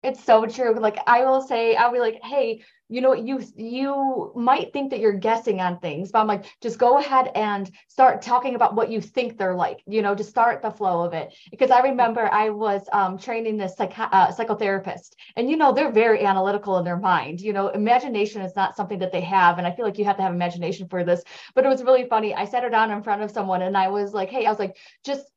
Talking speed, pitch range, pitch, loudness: 255 wpm, 195-245 Hz, 215 Hz, -22 LUFS